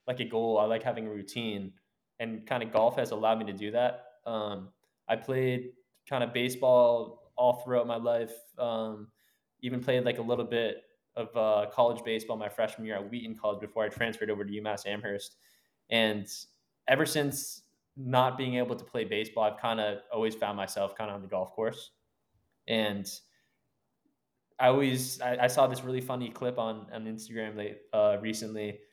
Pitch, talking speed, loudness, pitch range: 115 Hz, 185 wpm, -31 LUFS, 105-125 Hz